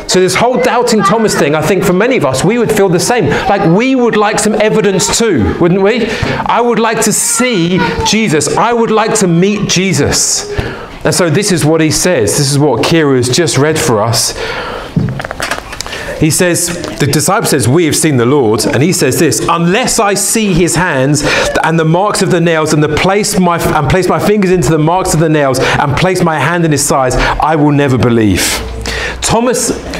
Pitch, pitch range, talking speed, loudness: 180 Hz, 155-210 Hz, 210 wpm, -10 LUFS